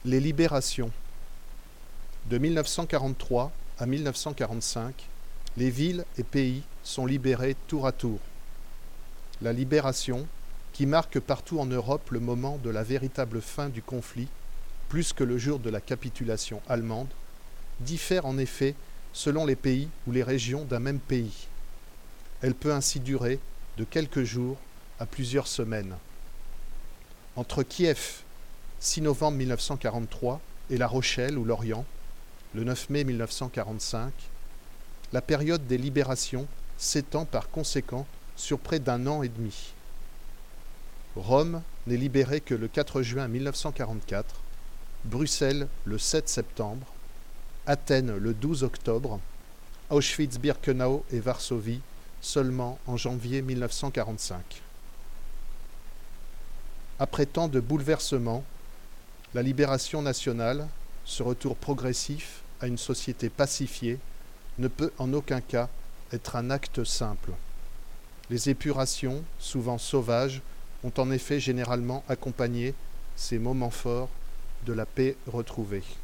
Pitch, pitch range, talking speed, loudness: 125 Hz, 115-140 Hz, 120 wpm, -30 LUFS